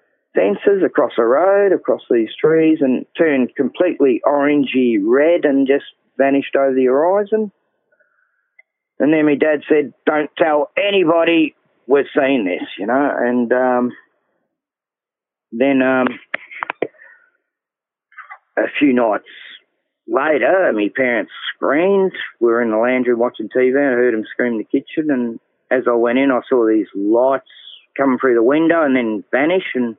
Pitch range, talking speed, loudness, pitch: 125-195 Hz, 150 wpm, -16 LUFS, 140 Hz